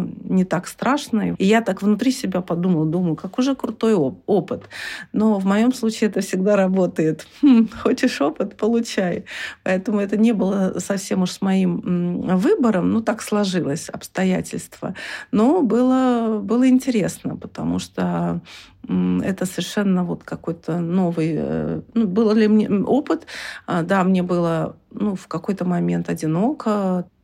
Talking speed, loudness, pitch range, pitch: 140 wpm, -20 LUFS, 175-225 Hz, 195 Hz